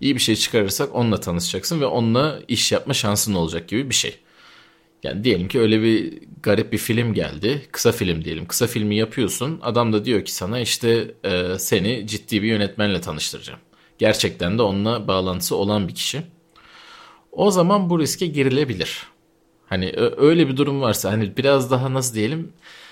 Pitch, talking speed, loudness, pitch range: 115 Hz, 165 wpm, -20 LUFS, 105-140 Hz